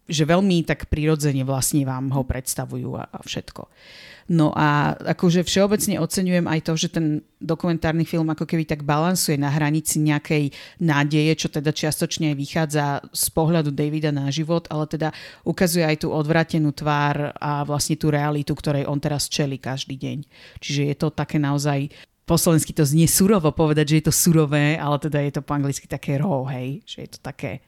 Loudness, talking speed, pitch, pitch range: -21 LUFS, 180 wpm, 155 Hz, 145-165 Hz